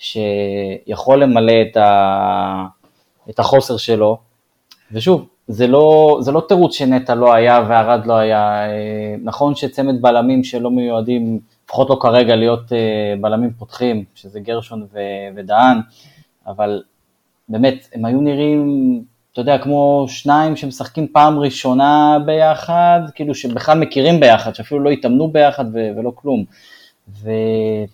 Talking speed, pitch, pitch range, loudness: 125 wpm, 120 Hz, 110-140 Hz, -14 LUFS